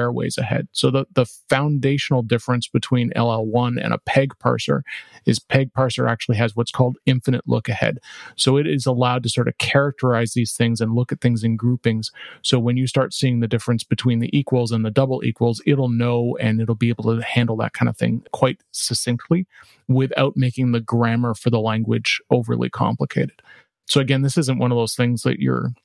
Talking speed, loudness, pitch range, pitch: 200 wpm, -20 LUFS, 115-130 Hz, 120 Hz